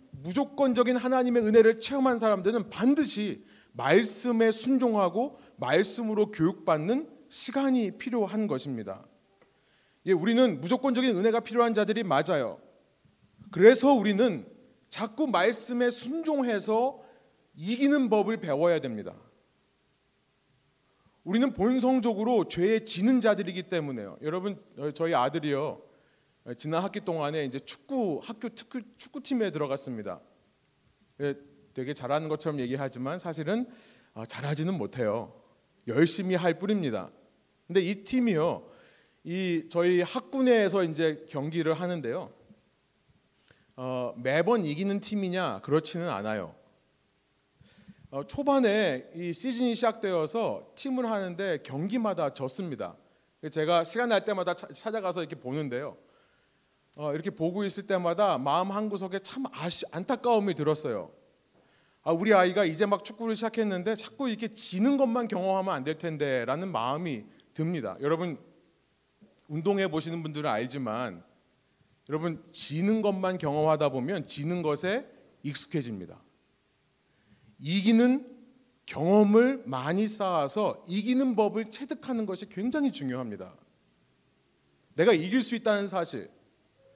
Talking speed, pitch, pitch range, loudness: 280 characters per minute, 195 Hz, 155-235 Hz, -28 LUFS